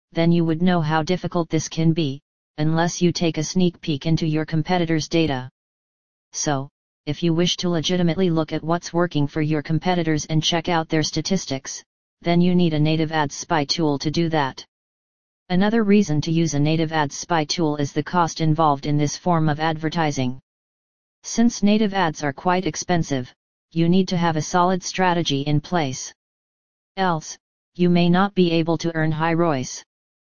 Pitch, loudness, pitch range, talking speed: 165 Hz, -21 LUFS, 155-175 Hz, 180 wpm